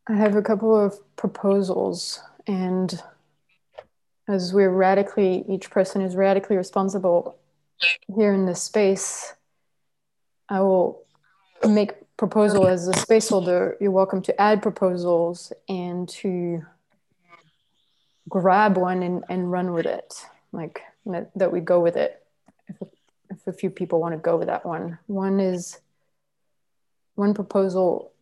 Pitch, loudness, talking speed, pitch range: 190 Hz, -22 LUFS, 130 wpm, 180-200 Hz